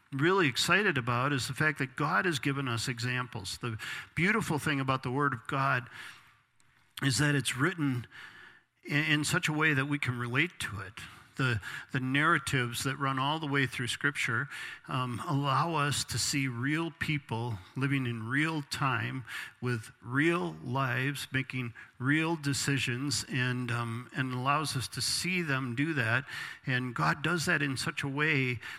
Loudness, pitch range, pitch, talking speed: -31 LUFS, 125-150 Hz, 135 Hz, 165 wpm